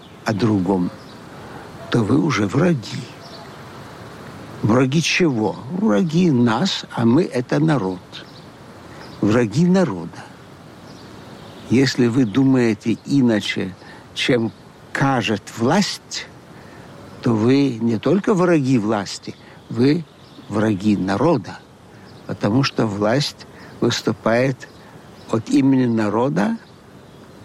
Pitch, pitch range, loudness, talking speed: 125 Hz, 110-145 Hz, -19 LUFS, 85 wpm